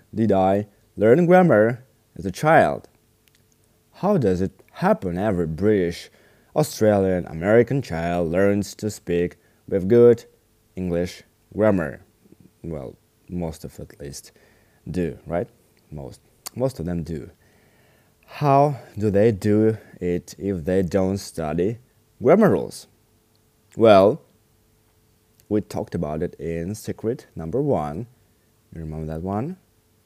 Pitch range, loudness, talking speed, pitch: 90-110 Hz, -21 LUFS, 120 wpm, 105 Hz